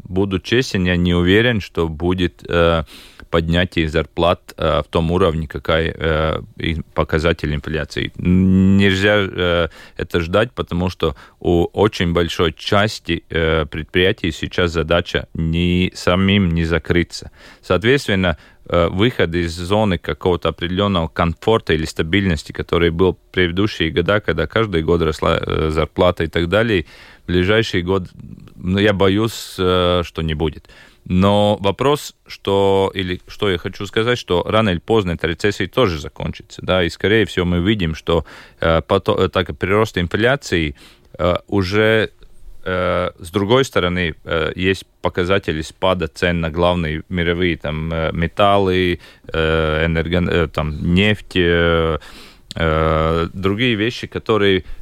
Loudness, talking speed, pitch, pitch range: -18 LUFS, 135 wpm, 90 Hz, 80-100 Hz